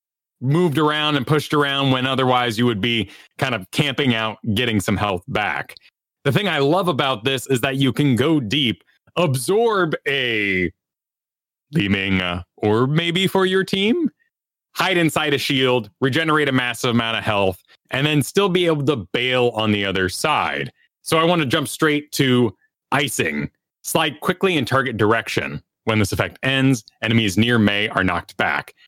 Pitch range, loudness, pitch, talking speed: 110-155 Hz, -19 LUFS, 130 Hz, 170 wpm